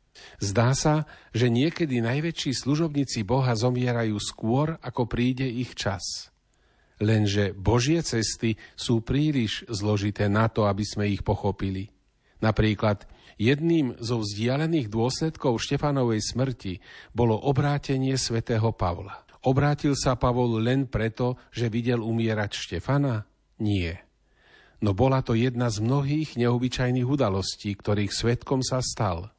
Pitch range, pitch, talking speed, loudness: 105-130 Hz, 120 Hz, 120 wpm, -26 LUFS